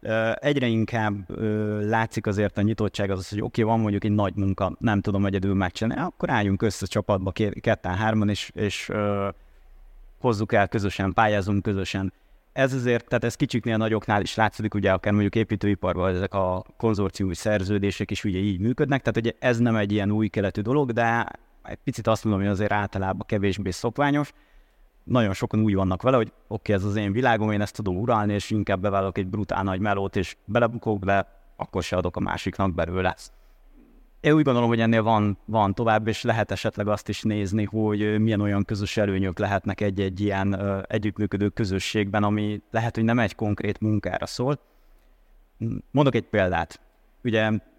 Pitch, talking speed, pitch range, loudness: 105 Hz, 185 wpm, 100-115 Hz, -25 LUFS